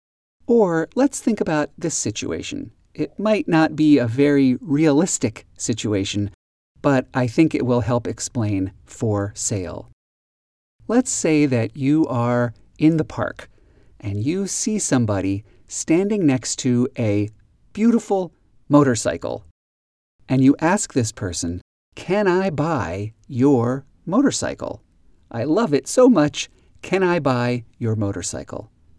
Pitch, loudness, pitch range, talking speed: 125 Hz, -20 LUFS, 105-160 Hz, 125 wpm